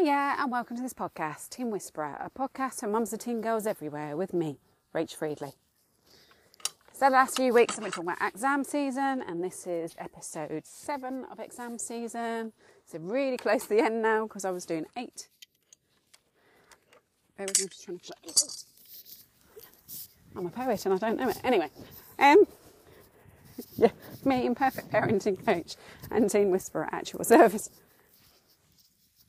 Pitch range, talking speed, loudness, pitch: 180-260 Hz, 150 wpm, -29 LUFS, 220 Hz